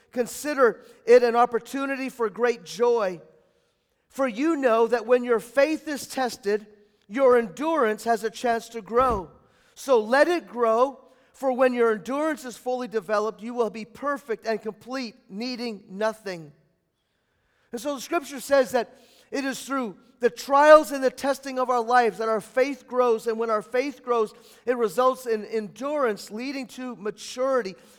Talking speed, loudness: 160 wpm, -24 LUFS